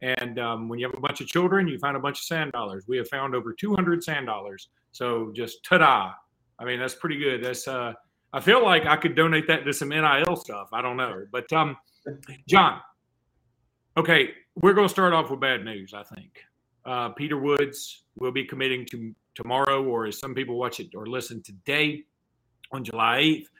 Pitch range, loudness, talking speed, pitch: 120-155 Hz, -24 LUFS, 210 wpm, 135 Hz